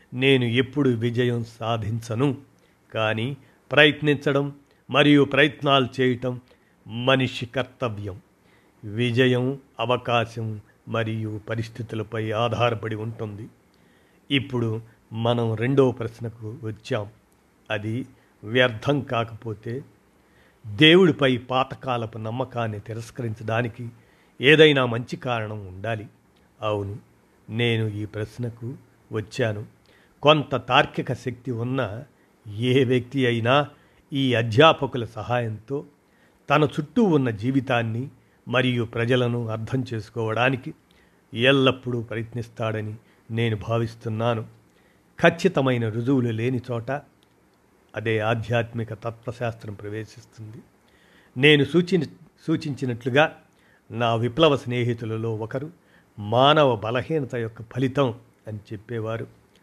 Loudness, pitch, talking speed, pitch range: -23 LUFS, 120 Hz, 80 wpm, 110-135 Hz